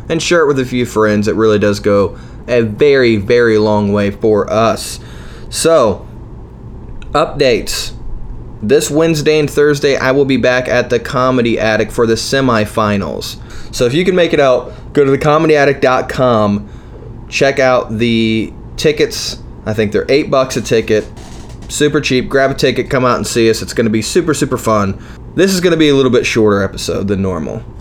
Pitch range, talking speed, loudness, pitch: 110-140 Hz, 185 wpm, -12 LUFS, 120 Hz